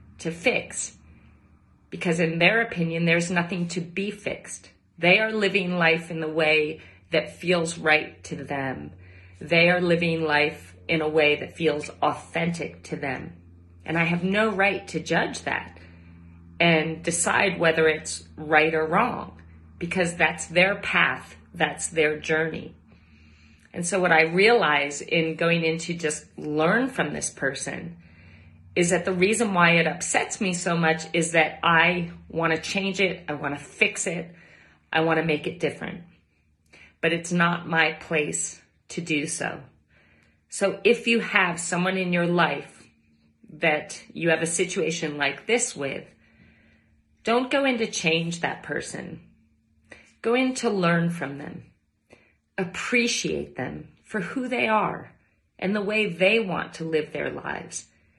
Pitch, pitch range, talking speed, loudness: 165 Hz, 150-180 Hz, 150 wpm, -24 LUFS